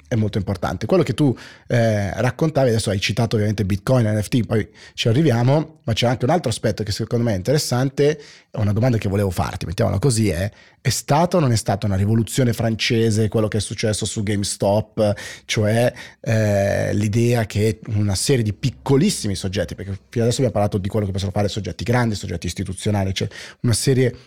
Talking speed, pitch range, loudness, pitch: 195 wpm, 105-125 Hz, -20 LUFS, 110 Hz